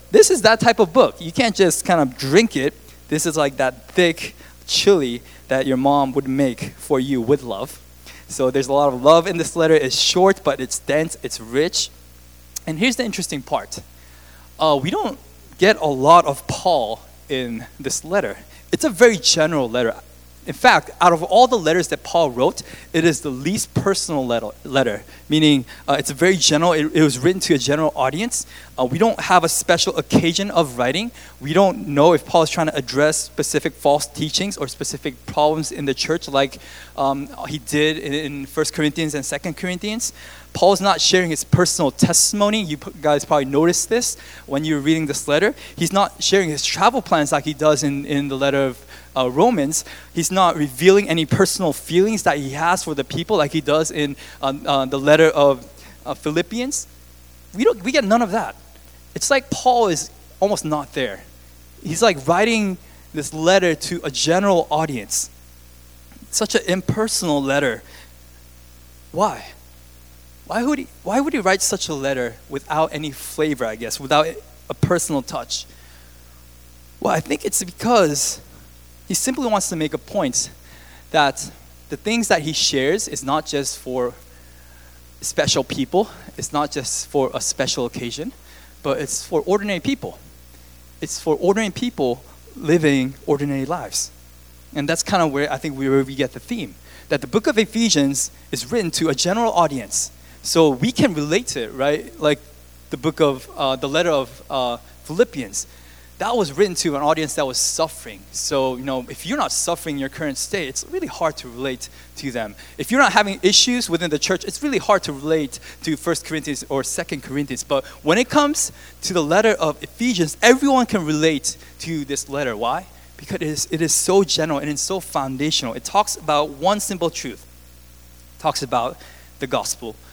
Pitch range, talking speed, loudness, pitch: 125-175 Hz, 185 wpm, -19 LUFS, 150 Hz